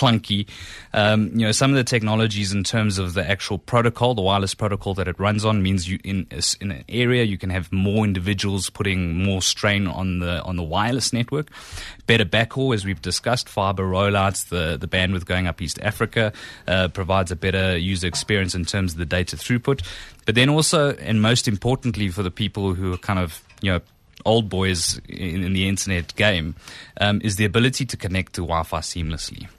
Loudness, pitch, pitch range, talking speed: -22 LUFS, 100 Hz, 90-110 Hz, 200 wpm